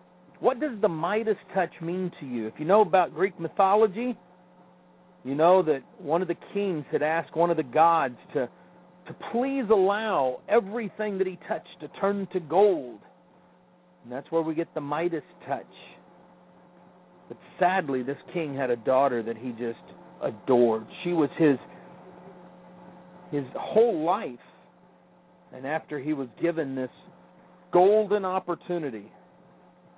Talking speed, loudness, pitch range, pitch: 145 wpm, -26 LUFS, 150-190 Hz, 175 Hz